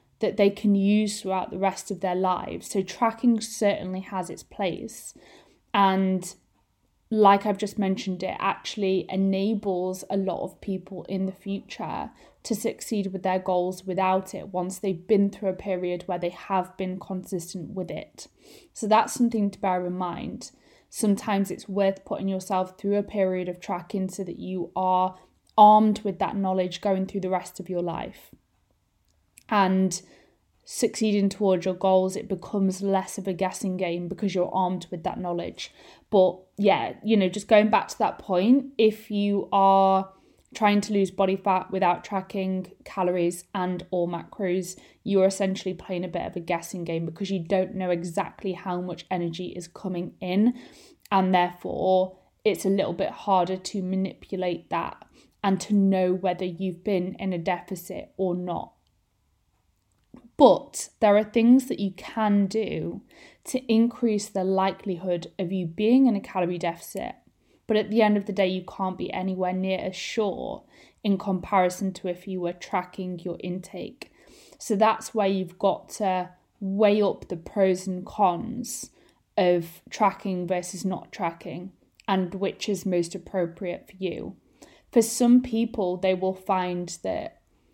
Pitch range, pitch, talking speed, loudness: 180-205 Hz, 190 Hz, 165 wpm, -26 LUFS